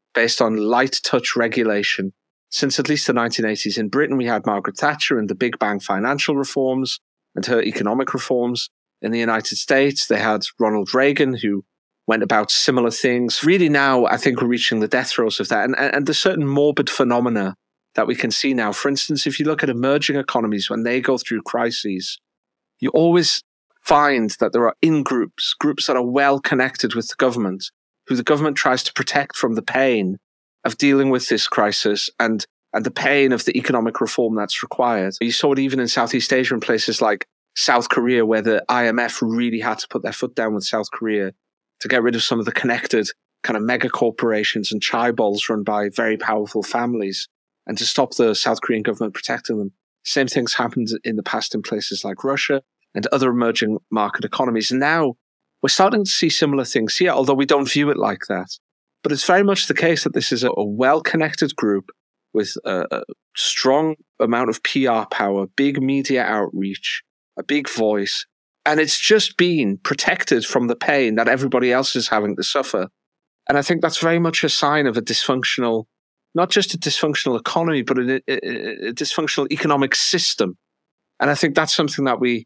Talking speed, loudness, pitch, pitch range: 195 wpm, -19 LUFS, 130 Hz, 115-145 Hz